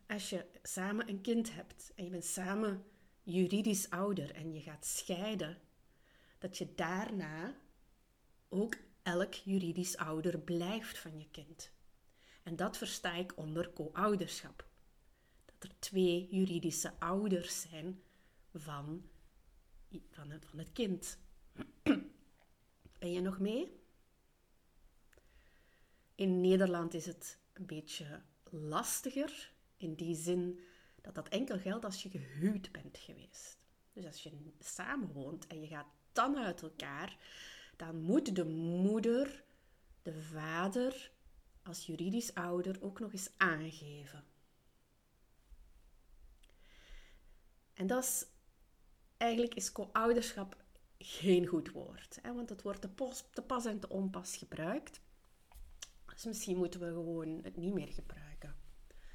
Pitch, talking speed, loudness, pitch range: 180 Hz, 120 wpm, -39 LUFS, 160-200 Hz